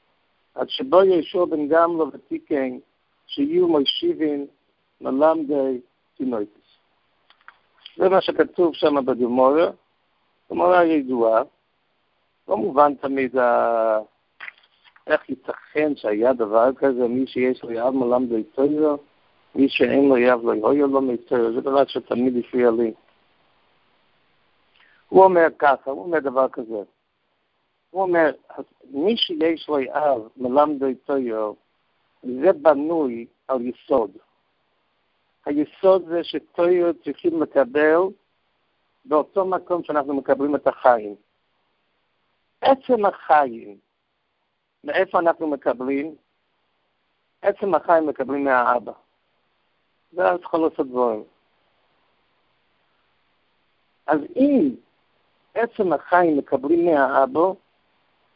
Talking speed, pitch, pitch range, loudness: 100 wpm, 145 Hz, 130-170 Hz, -21 LUFS